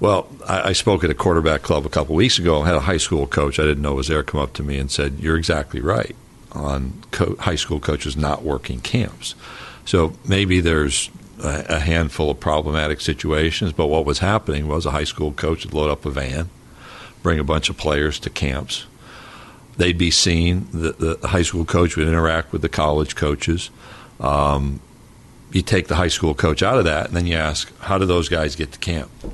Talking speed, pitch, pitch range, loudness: 215 wpm, 80 Hz, 75-85 Hz, -20 LUFS